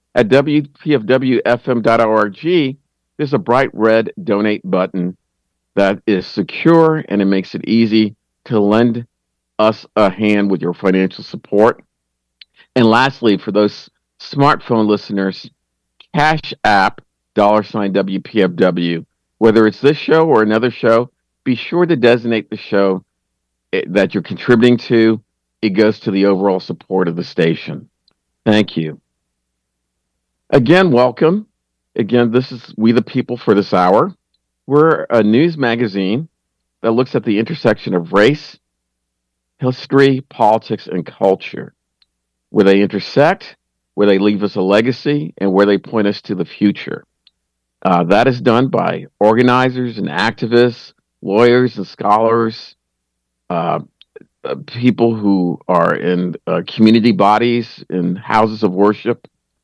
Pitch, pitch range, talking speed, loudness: 105 Hz, 90-120 Hz, 130 wpm, -14 LUFS